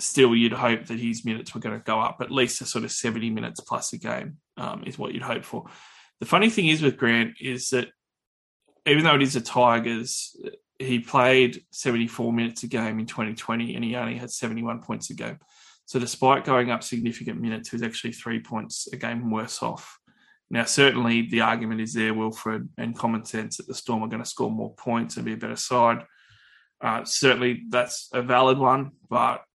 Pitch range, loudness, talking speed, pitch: 115-130 Hz, -24 LUFS, 210 wpm, 120 Hz